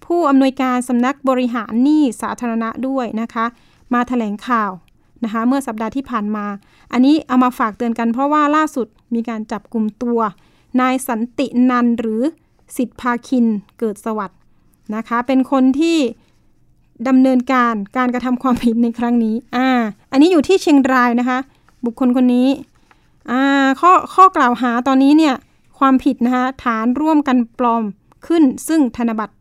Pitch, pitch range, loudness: 250 Hz, 230-270 Hz, -16 LUFS